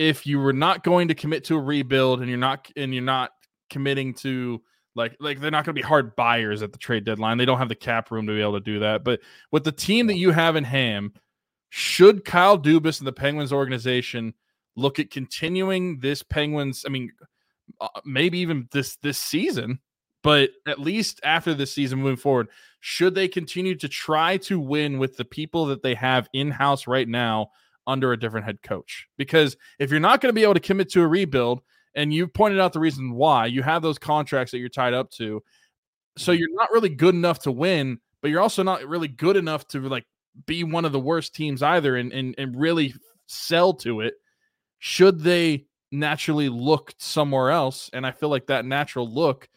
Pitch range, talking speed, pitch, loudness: 130-165 Hz, 210 wpm, 145 Hz, -23 LUFS